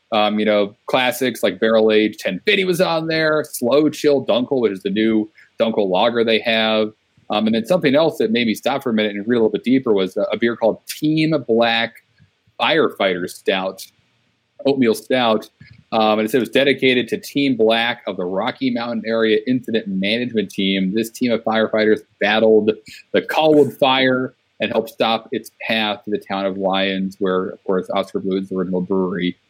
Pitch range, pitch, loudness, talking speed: 105-130 Hz, 110 Hz, -18 LUFS, 195 wpm